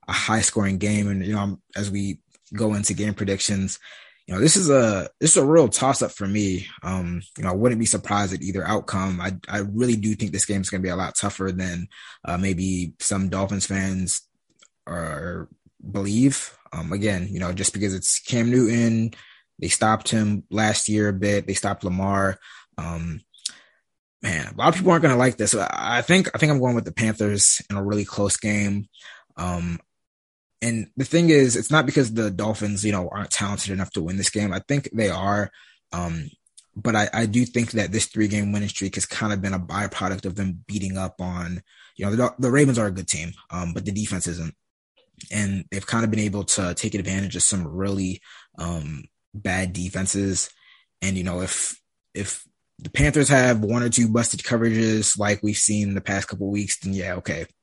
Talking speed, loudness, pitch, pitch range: 210 wpm, -22 LUFS, 100 Hz, 95-110 Hz